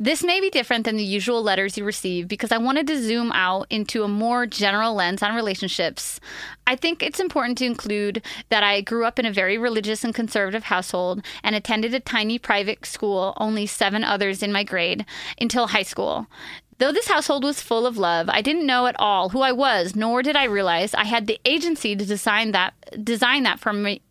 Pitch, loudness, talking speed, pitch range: 220 Hz, -22 LUFS, 210 wpm, 205-245 Hz